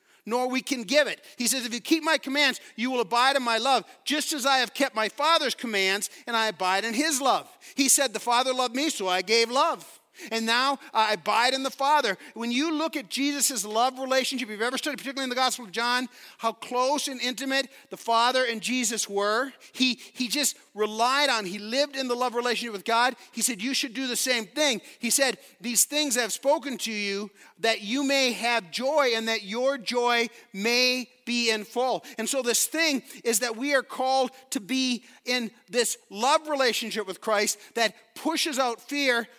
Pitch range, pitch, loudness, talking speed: 230-275 Hz, 250 Hz, -25 LUFS, 210 wpm